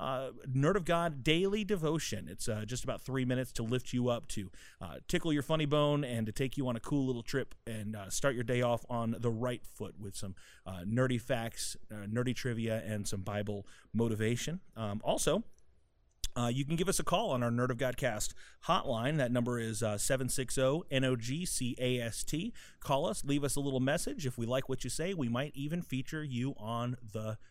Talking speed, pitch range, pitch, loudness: 205 wpm, 115-140 Hz, 125 Hz, -35 LUFS